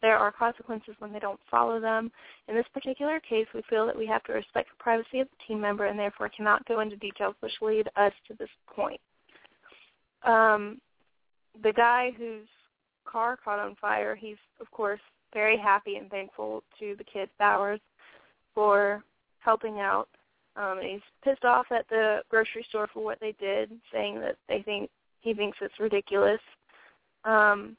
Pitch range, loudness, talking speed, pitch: 205-230 Hz, -28 LUFS, 175 wpm, 215 Hz